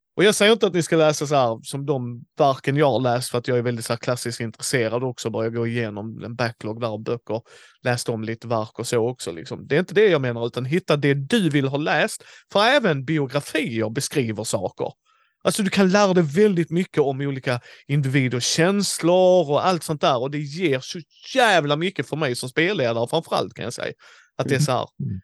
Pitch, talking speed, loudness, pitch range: 140 Hz, 225 wpm, -22 LUFS, 120-165 Hz